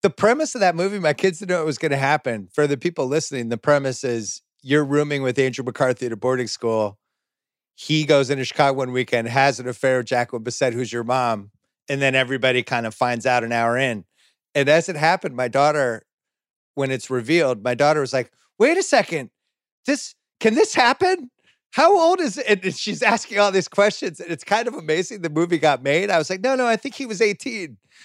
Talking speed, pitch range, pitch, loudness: 220 wpm, 125-190 Hz, 145 Hz, -20 LUFS